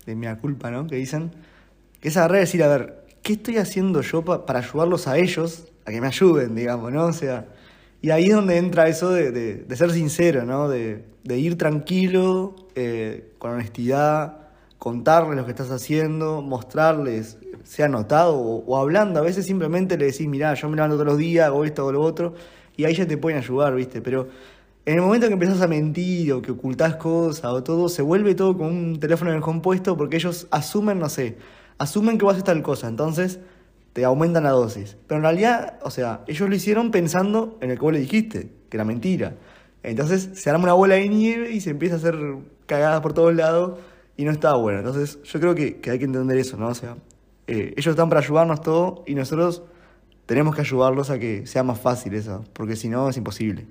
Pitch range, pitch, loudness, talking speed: 130-175 Hz, 155 Hz, -21 LUFS, 220 wpm